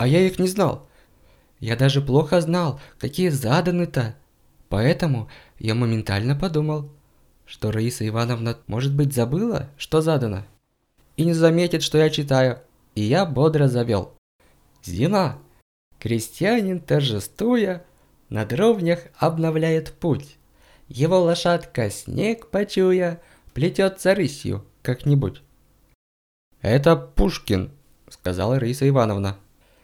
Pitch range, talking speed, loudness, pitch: 115-170 Hz, 105 wpm, -22 LUFS, 140 Hz